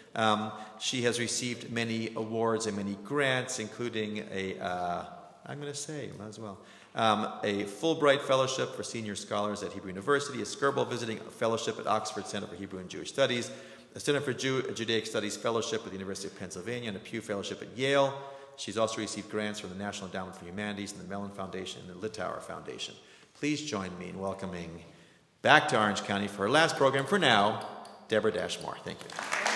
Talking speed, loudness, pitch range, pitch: 195 wpm, -31 LUFS, 100-125 Hz, 105 Hz